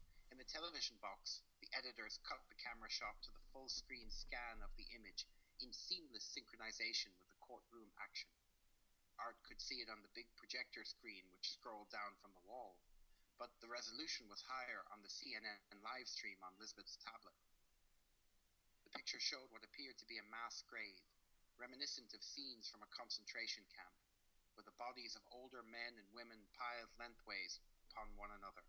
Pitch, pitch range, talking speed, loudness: 105 Hz, 100-120 Hz, 170 wpm, -51 LUFS